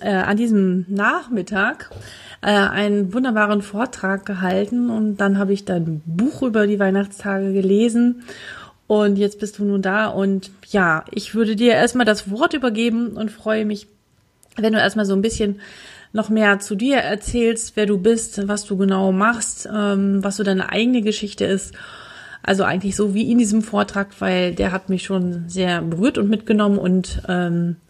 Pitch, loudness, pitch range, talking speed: 205 Hz, -19 LUFS, 195-220 Hz, 170 wpm